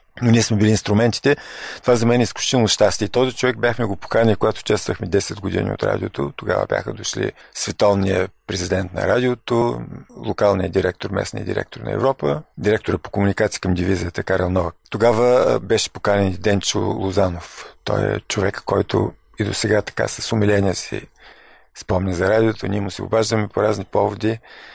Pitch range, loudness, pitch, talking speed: 95-115 Hz, -20 LUFS, 105 Hz, 165 wpm